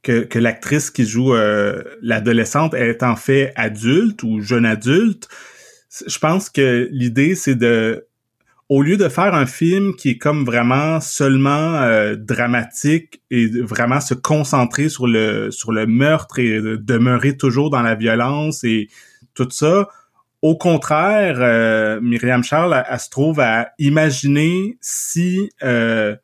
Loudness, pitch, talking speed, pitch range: -16 LUFS, 130 Hz, 145 wpm, 115-155 Hz